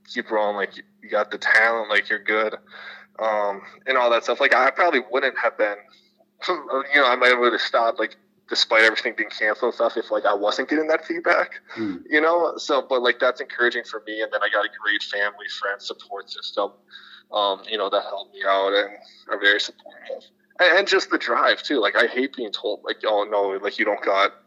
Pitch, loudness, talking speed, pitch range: 110 Hz, -21 LUFS, 215 wpm, 105-135 Hz